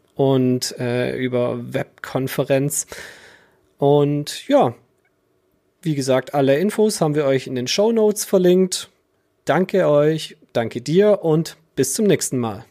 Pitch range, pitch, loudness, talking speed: 130-185 Hz, 145 Hz, -19 LUFS, 130 wpm